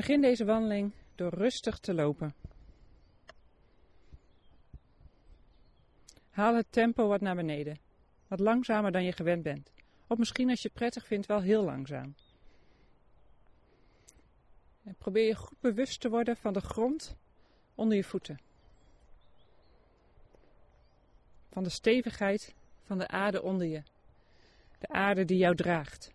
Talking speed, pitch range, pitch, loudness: 125 wpm, 165-225 Hz, 200 Hz, -31 LUFS